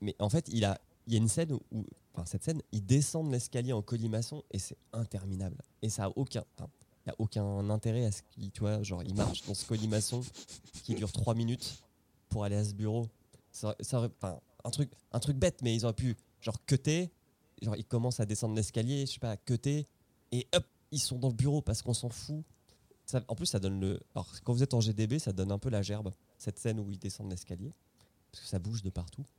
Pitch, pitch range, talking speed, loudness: 115 Hz, 100-125 Hz, 225 wpm, -35 LUFS